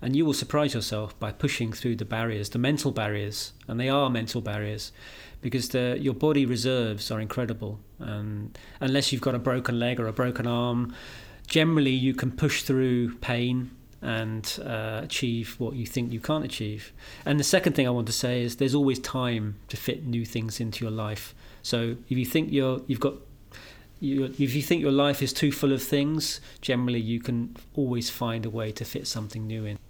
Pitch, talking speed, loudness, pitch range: 125 Hz, 200 wpm, -27 LUFS, 110-135 Hz